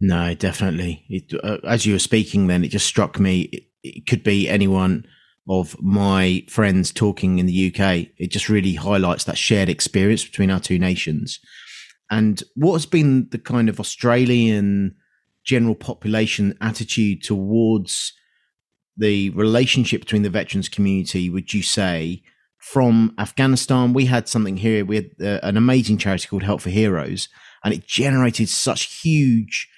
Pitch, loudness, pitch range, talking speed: 105 Hz, -19 LUFS, 95-115 Hz, 155 wpm